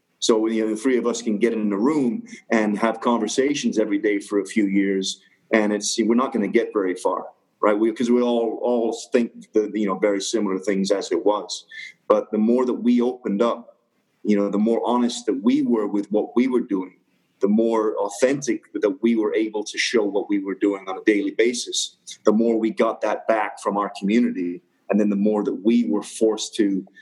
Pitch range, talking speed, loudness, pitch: 105-120 Hz, 225 wpm, -22 LUFS, 110 Hz